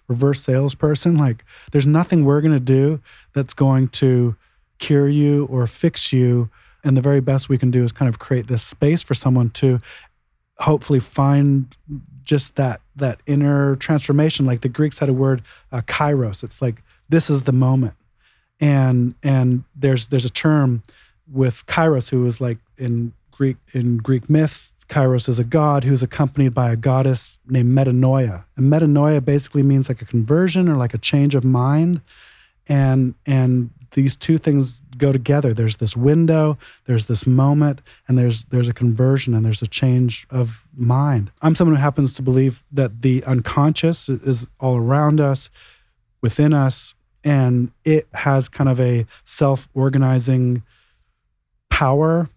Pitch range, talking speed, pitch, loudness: 125-145 Hz, 165 wpm, 135 Hz, -18 LUFS